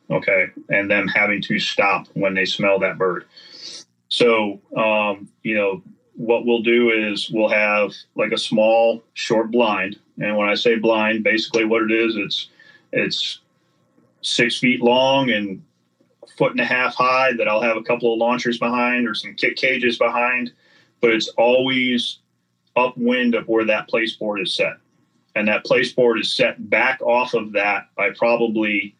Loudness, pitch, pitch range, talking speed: -19 LUFS, 115 Hz, 105-120 Hz, 170 wpm